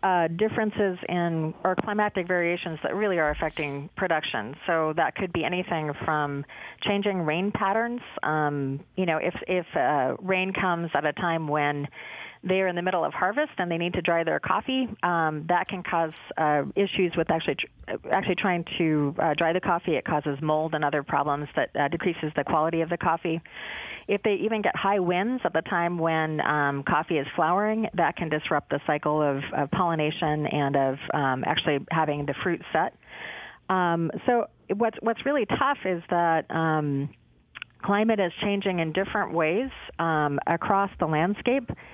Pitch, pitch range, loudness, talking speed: 170 Hz, 150-190 Hz, -26 LUFS, 175 wpm